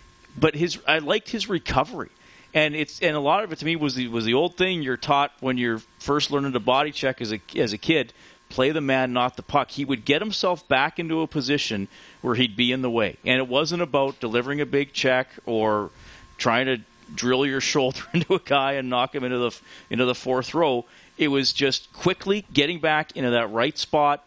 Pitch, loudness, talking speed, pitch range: 135 Hz, -23 LUFS, 225 wpm, 125-155 Hz